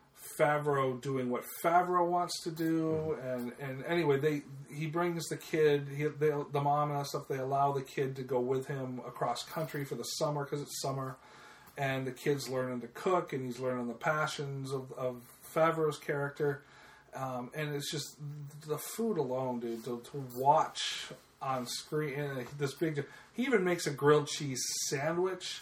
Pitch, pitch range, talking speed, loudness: 145 Hz, 130-155 Hz, 180 wpm, -34 LUFS